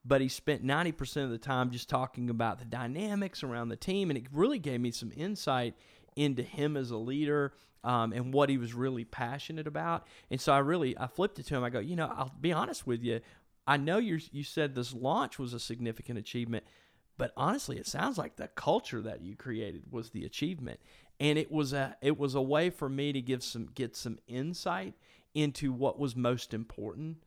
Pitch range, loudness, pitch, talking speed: 120-150 Hz, -34 LUFS, 135 Hz, 215 wpm